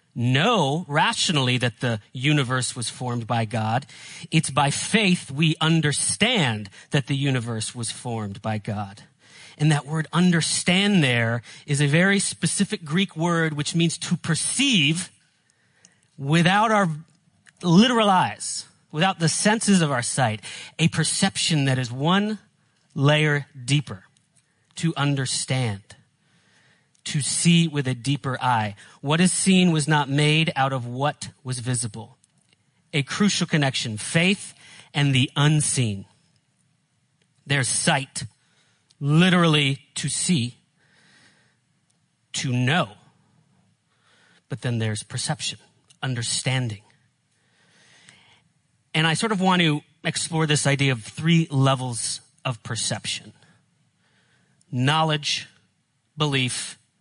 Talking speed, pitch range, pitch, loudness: 115 wpm, 130-165 Hz, 145 Hz, -22 LUFS